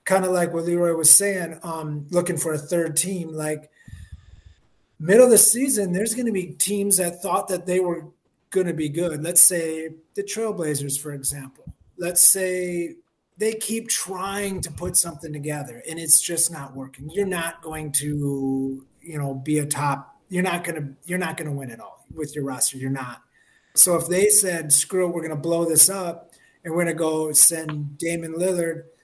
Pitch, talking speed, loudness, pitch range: 165 Hz, 190 wpm, -18 LUFS, 150-180 Hz